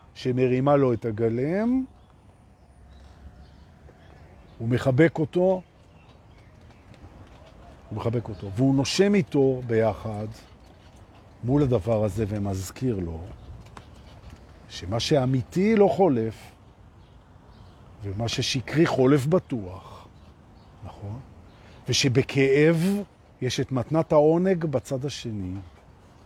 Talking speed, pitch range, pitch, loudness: 80 wpm, 100-135 Hz, 115 Hz, -24 LUFS